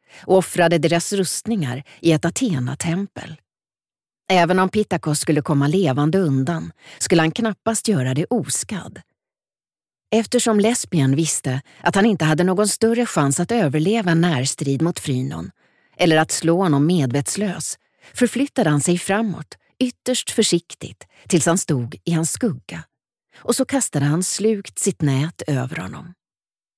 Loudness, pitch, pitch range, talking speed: -19 LUFS, 170 Hz, 150-210 Hz, 140 wpm